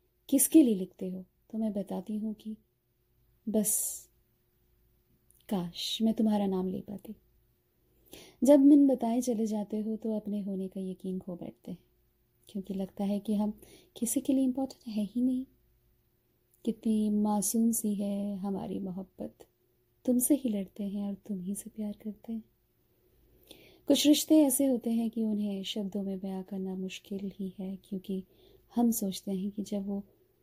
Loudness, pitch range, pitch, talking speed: -30 LUFS, 190-225 Hz, 205 Hz, 160 wpm